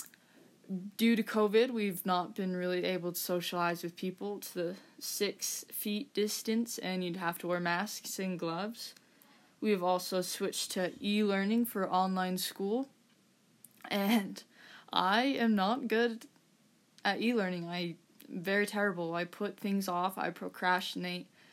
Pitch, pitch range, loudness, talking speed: 195 Hz, 180-220 Hz, -34 LUFS, 145 wpm